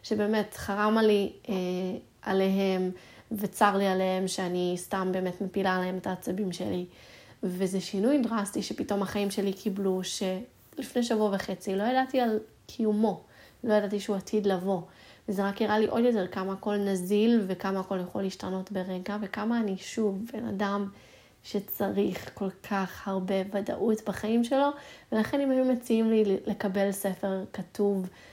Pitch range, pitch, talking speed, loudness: 190-215 Hz, 200 Hz, 150 wpm, -29 LUFS